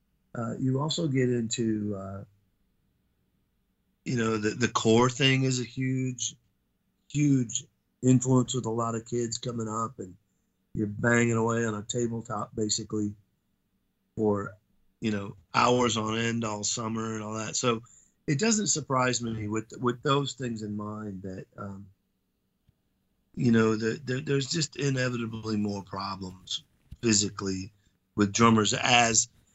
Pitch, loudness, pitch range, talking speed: 115 Hz, -28 LUFS, 105-125 Hz, 140 wpm